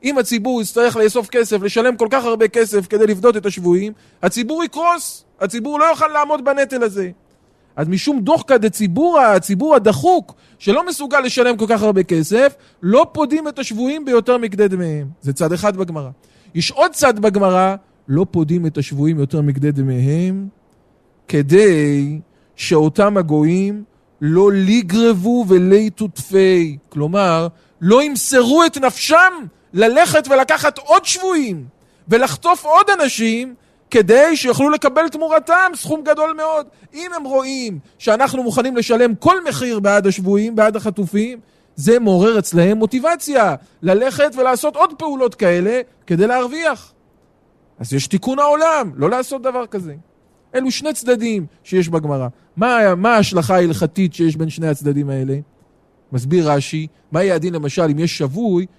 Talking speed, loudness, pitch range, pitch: 140 wpm, -15 LUFS, 175-265 Hz, 215 Hz